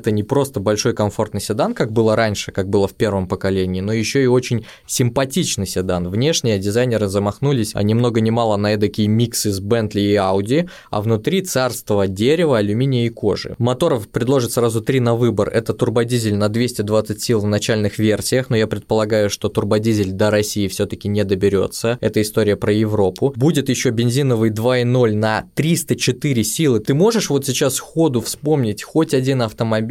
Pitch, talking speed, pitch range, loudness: 110 Hz, 175 wpm, 105-125 Hz, -18 LUFS